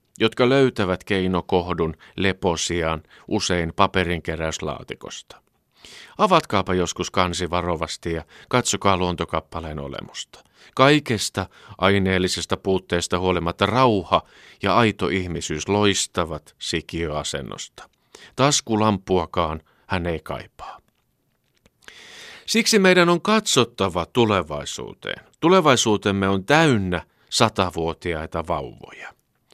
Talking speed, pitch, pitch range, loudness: 75 wpm, 95 Hz, 85-110 Hz, -21 LUFS